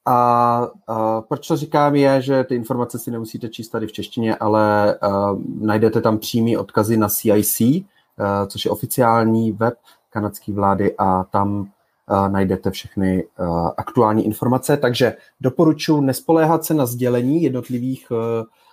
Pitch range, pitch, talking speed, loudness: 105-125 Hz, 115 Hz, 145 wpm, -19 LUFS